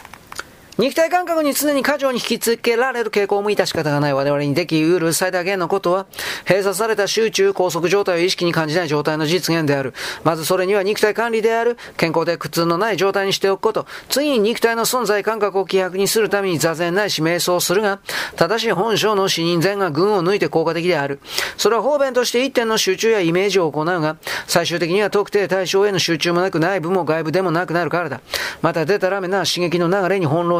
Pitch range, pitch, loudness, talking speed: 170-210 Hz, 190 Hz, -18 LUFS, 420 characters per minute